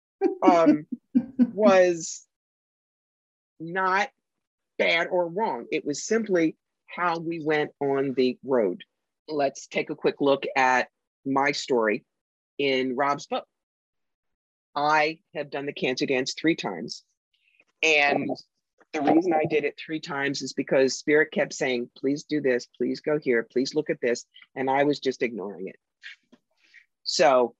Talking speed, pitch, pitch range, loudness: 140 wpm, 150 Hz, 135-170 Hz, -25 LUFS